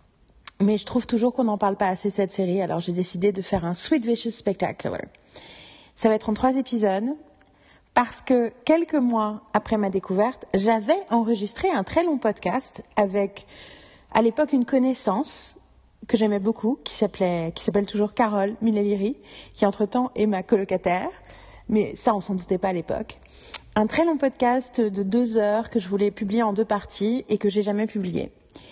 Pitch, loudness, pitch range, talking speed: 215 Hz, -24 LUFS, 200-240 Hz, 180 wpm